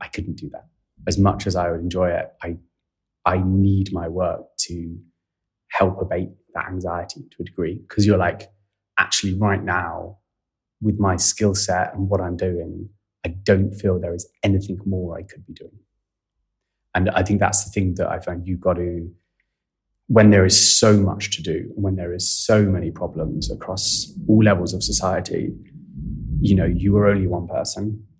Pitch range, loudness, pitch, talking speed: 90-100 Hz, -20 LUFS, 95 Hz, 185 wpm